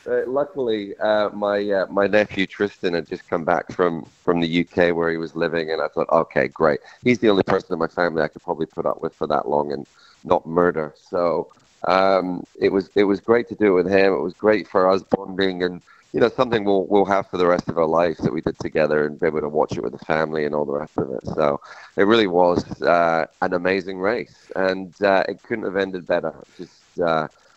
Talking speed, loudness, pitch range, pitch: 240 wpm, -21 LUFS, 85-100 Hz, 95 Hz